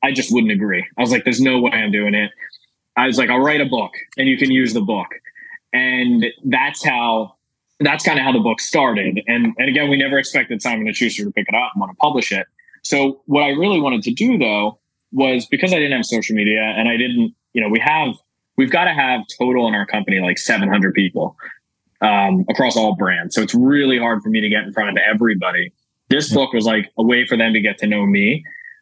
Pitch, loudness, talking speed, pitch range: 125 Hz, -17 LUFS, 235 wpm, 110-145 Hz